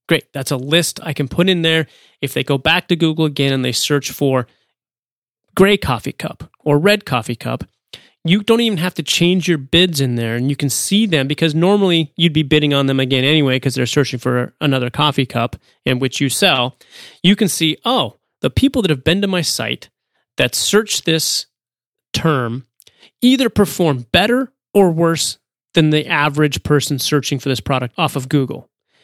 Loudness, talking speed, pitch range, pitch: -16 LUFS, 195 wpm, 135-175 Hz, 150 Hz